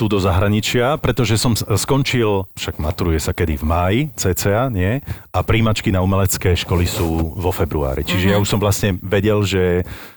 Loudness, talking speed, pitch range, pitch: -18 LUFS, 170 wpm, 90-110 Hz, 100 Hz